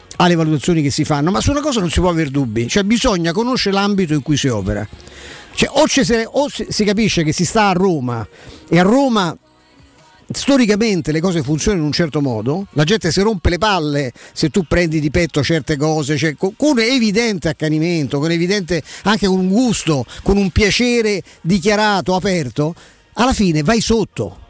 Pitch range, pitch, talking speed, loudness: 155-210 Hz, 175 Hz, 185 wpm, -16 LUFS